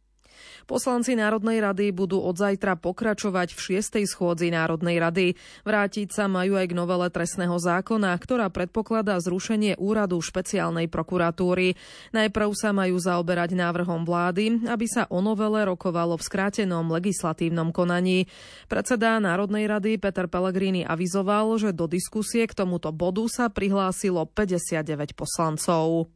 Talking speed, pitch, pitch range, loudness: 130 wpm, 185 Hz, 175-210 Hz, -25 LUFS